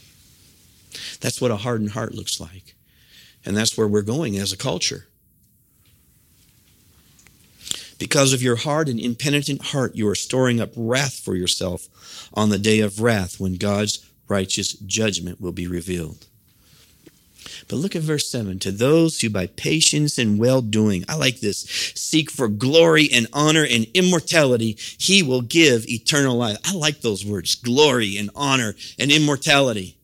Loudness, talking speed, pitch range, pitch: -20 LUFS, 155 wpm, 100-140 Hz, 115 Hz